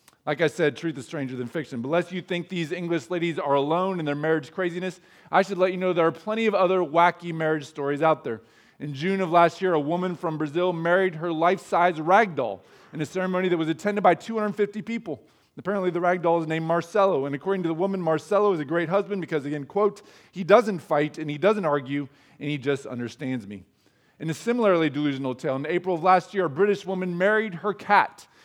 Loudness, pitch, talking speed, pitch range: -25 LUFS, 175 Hz, 225 wpm, 150-185 Hz